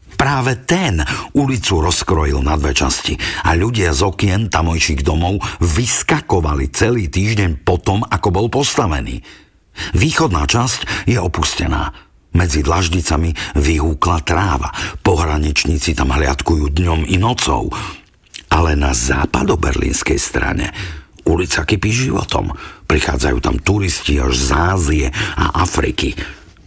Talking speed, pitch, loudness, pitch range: 110 wpm, 85 Hz, -16 LUFS, 75-100 Hz